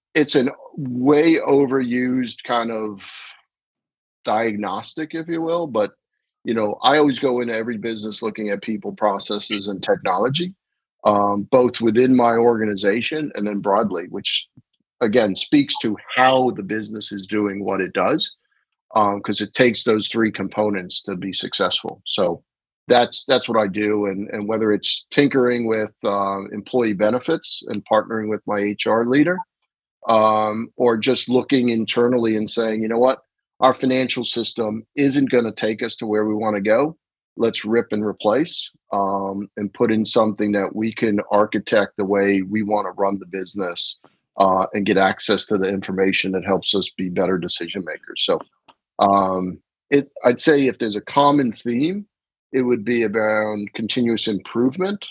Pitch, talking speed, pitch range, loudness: 110 Hz, 165 wpm, 105-125 Hz, -20 LUFS